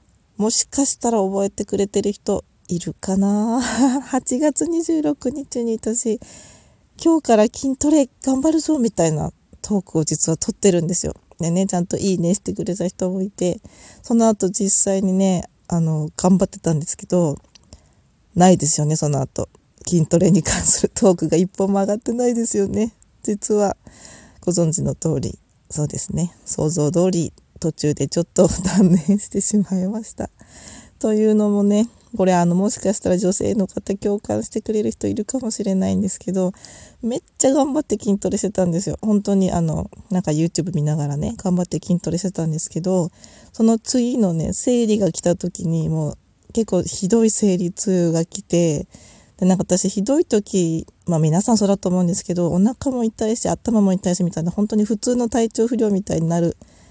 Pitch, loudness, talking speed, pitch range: 195 Hz, -19 LUFS, 350 characters per minute, 175-220 Hz